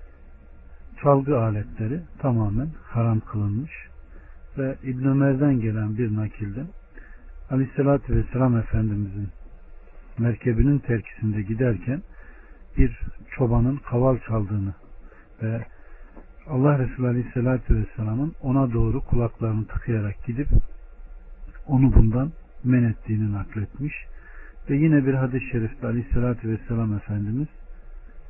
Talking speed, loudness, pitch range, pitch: 95 wpm, -24 LUFS, 105-130 Hz, 115 Hz